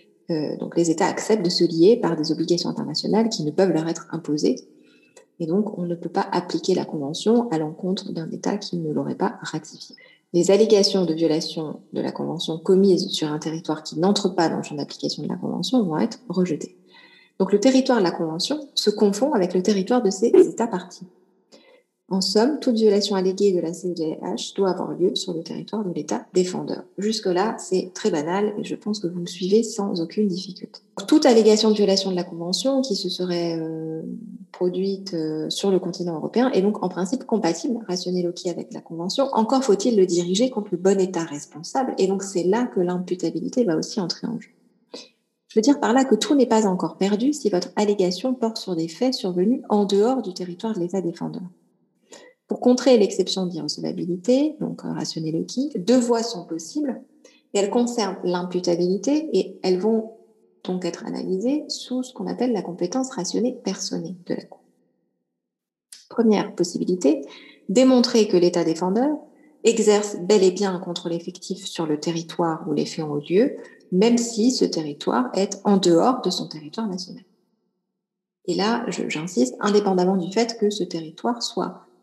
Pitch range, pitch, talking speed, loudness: 175-225 Hz, 190 Hz, 185 wpm, -22 LUFS